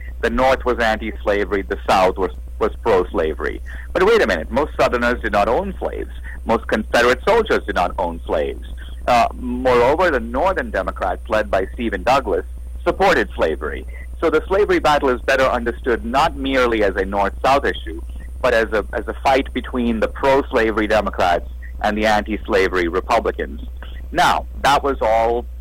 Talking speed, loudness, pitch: 170 wpm, -18 LUFS, 105 Hz